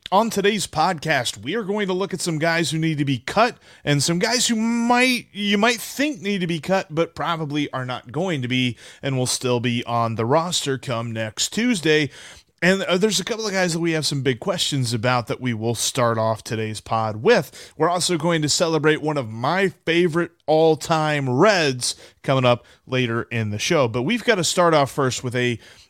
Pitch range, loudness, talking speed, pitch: 125-185 Hz, -21 LUFS, 215 wpm, 155 Hz